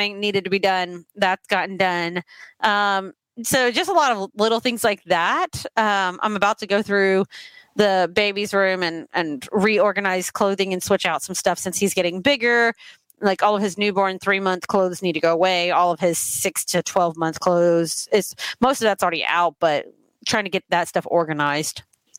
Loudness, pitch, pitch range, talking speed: -20 LUFS, 195 Hz, 175-210 Hz, 195 wpm